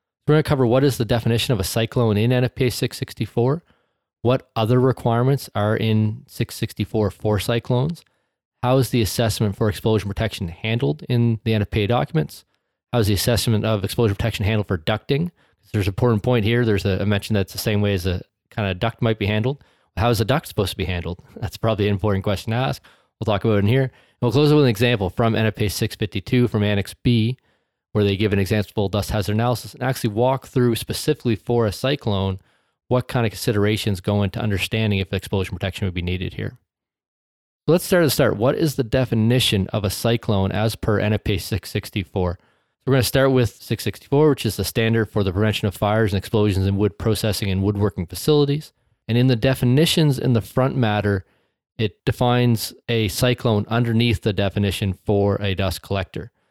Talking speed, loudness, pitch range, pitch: 200 wpm, -21 LUFS, 100-125 Hz, 110 Hz